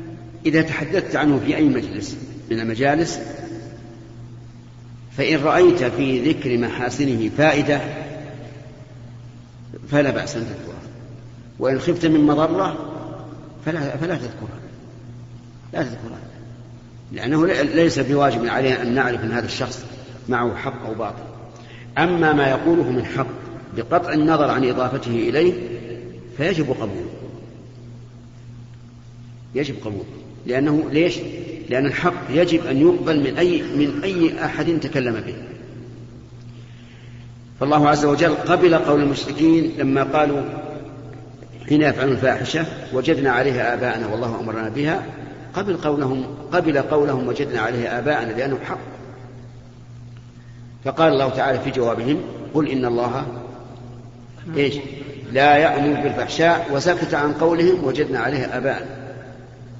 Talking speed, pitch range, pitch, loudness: 110 wpm, 120-150 Hz, 130 Hz, -20 LUFS